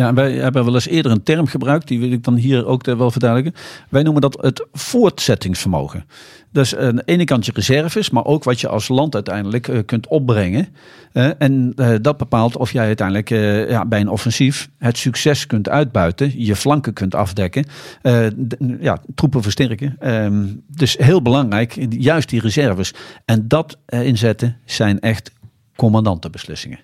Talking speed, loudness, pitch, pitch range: 155 wpm, -17 LUFS, 125 Hz, 110-140 Hz